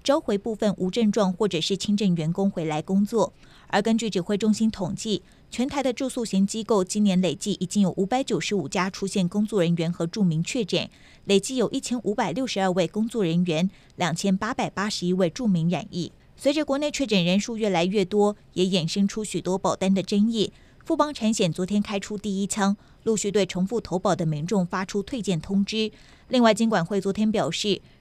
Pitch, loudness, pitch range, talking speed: 200 Hz, -25 LUFS, 185-220 Hz, 310 characters per minute